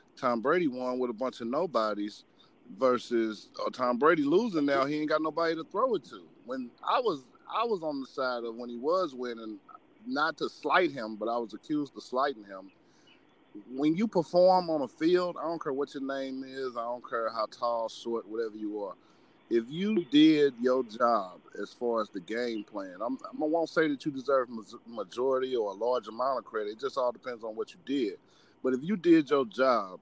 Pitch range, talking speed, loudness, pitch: 120-180 Hz, 215 wpm, -30 LUFS, 135 Hz